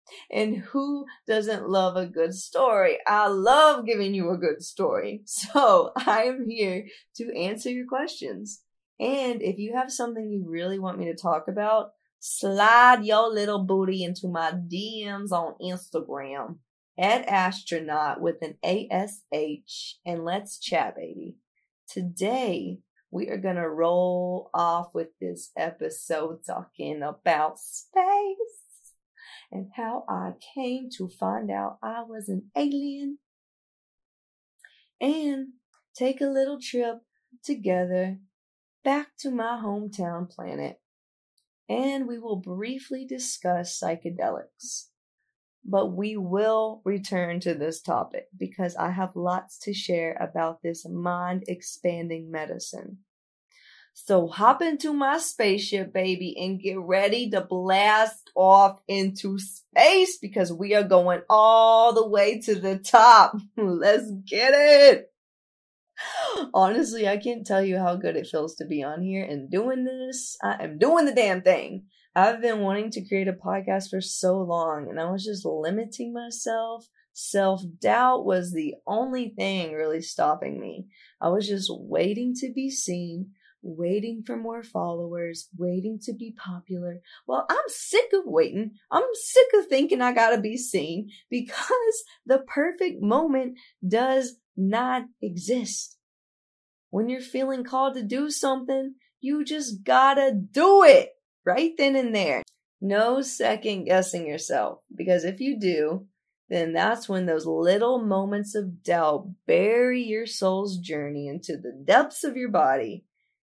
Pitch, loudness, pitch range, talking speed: 205 Hz, -24 LUFS, 180-250 Hz, 140 wpm